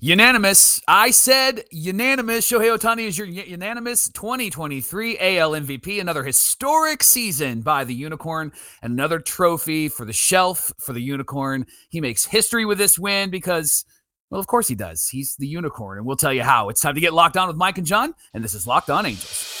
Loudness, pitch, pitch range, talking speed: -18 LUFS, 175 Hz, 140-215 Hz, 190 wpm